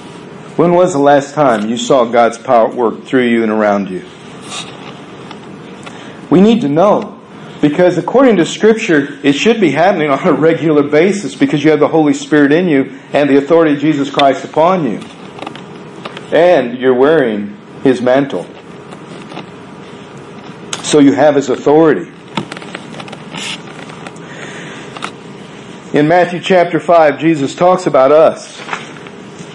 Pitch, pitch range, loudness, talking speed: 150 Hz, 140-180 Hz, -11 LUFS, 130 wpm